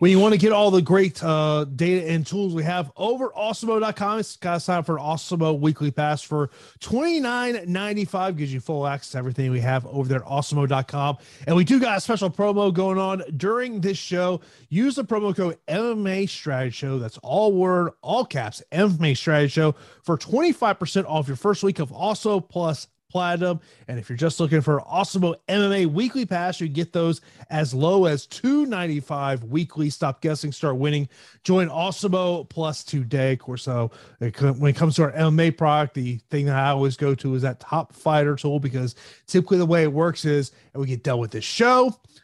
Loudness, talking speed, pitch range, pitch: -23 LUFS, 205 wpm, 140-190 Hz, 160 Hz